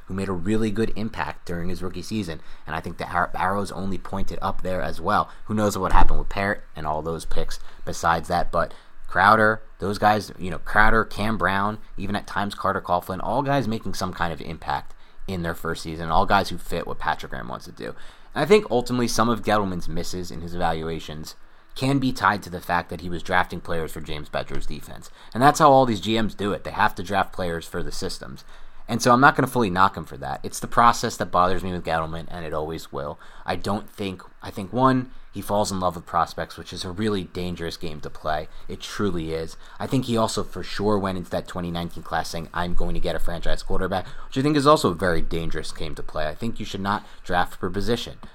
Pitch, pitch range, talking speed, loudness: 90 Hz, 85-105 Hz, 240 wpm, -24 LUFS